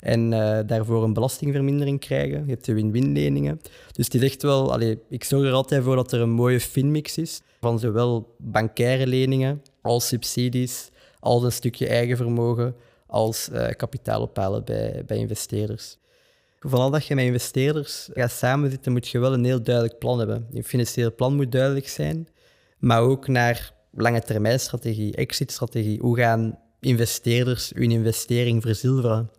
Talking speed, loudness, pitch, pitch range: 160 wpm, -23 LUFS, 120 Hz, 115-130 Hz